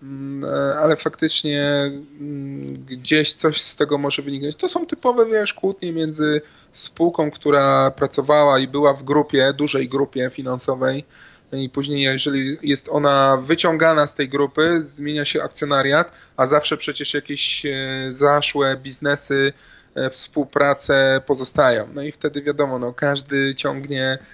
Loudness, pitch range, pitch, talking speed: -19 LUFS, 135-150 Hz, 145 Hz, 125 wpm